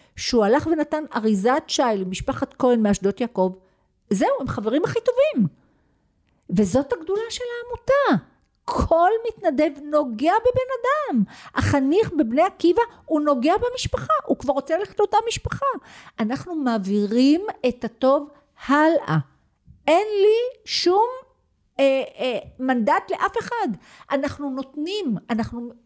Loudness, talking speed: -22 LUFS, 120 wpm